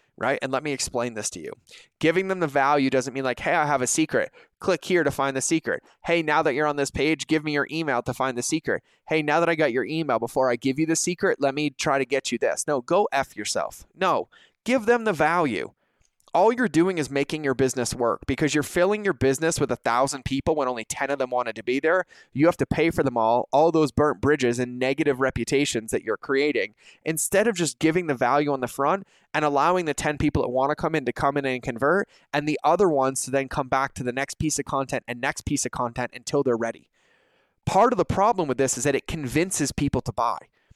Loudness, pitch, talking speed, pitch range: -24 LUFS, 140 Hz, 255 wpm, 130-160 Hz